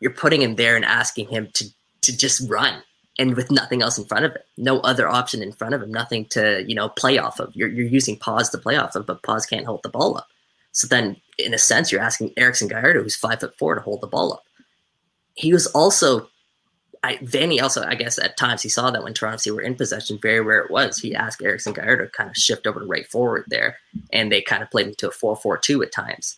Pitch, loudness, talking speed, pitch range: 125 Hz, -20 LUFS, 255 wpm, 110-130 Hz